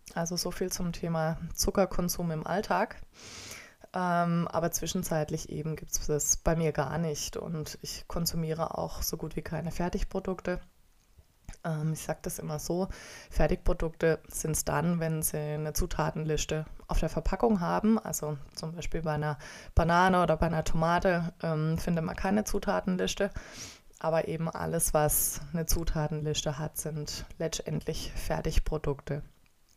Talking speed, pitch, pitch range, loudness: 145 wpm, 160 Hz, 155-175 Hz, -31 LUFS